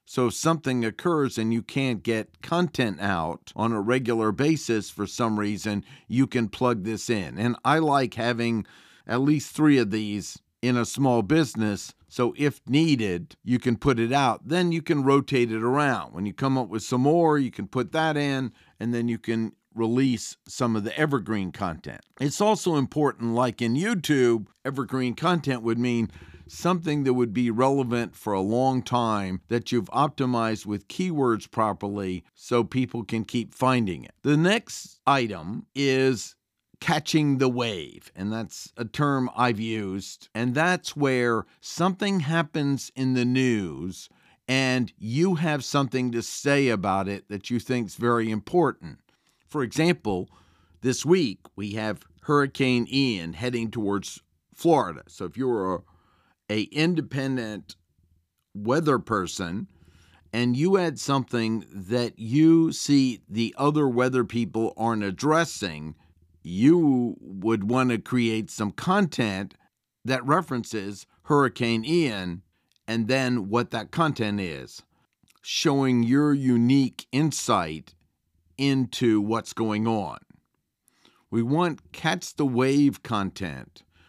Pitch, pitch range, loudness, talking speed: 120 Hz, 105-140 Hz, -25 LUFS, 145 wpm